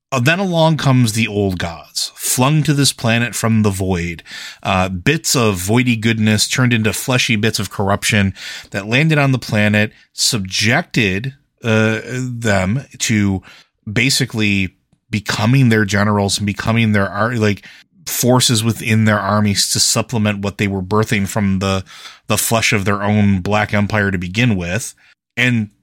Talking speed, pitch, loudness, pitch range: 150 wpm, 110 Hz, -16 LUFS, 100-120 Hz